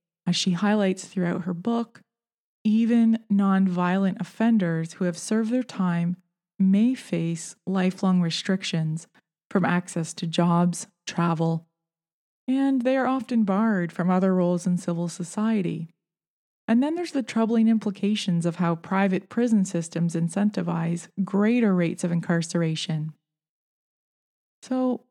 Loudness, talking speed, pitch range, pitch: -24 LUFS, 120 wpm, 170-220 Hz, 185 Hz